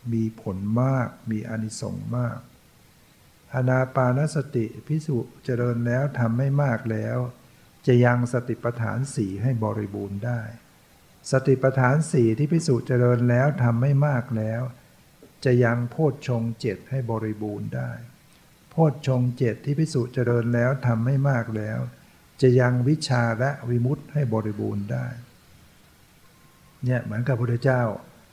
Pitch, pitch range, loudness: 120 Hz, 115-130 Hz, -24 LUFS